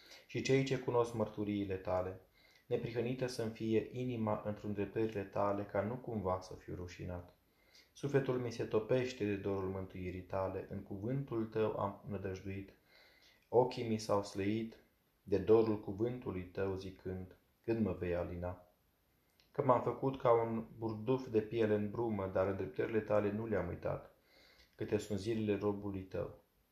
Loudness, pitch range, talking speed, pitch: -38 LUFS, 95-115 Hz, 150 wpm, 105 Hz